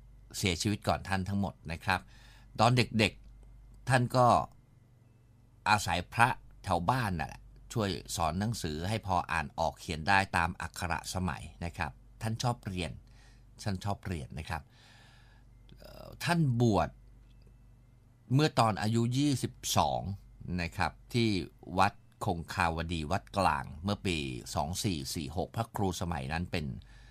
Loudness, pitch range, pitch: -32 LUFS, 90-115 Hz, 105 Hz